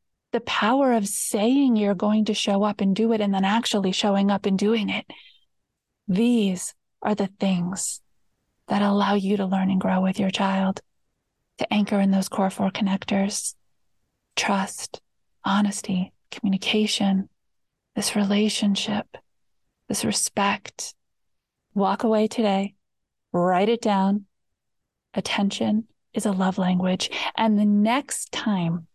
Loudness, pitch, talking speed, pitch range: -23 LUFS, 200 Hz, 130 wpm, 195-215 Hz